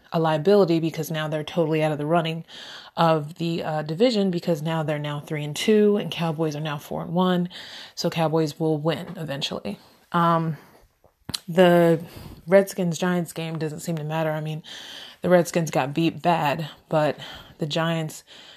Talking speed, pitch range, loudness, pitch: 170 wpm, 155-175 Hz, -23 LUFS, 165 Hz